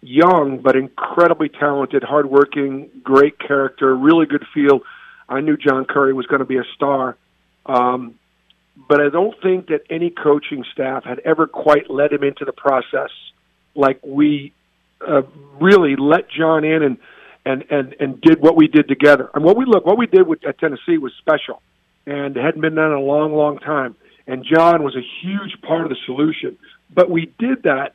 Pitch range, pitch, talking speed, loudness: 135-160 Hz, 145 Hz, 190 wpm, -16 LUFS